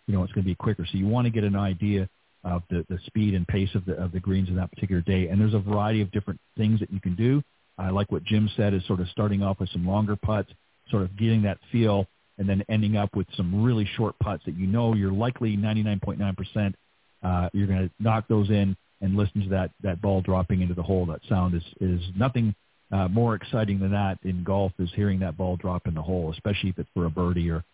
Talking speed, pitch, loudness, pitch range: 260 wpm, 100 Hz, -26 LUFS, 95-105 Hz